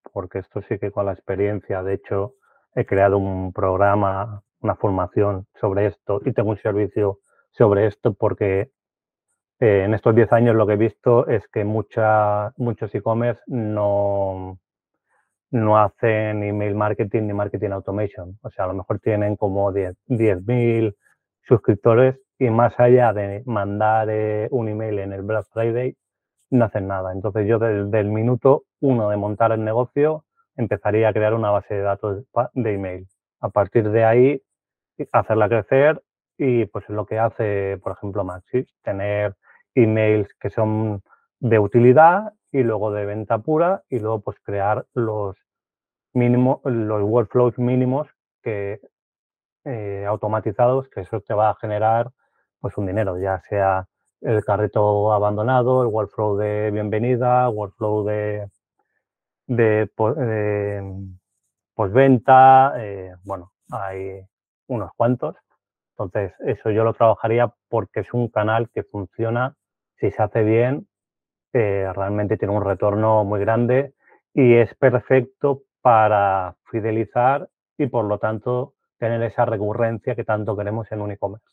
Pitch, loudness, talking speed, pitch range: 110 Hz, -20 LUFS, 145 wpm, 100-120 Hz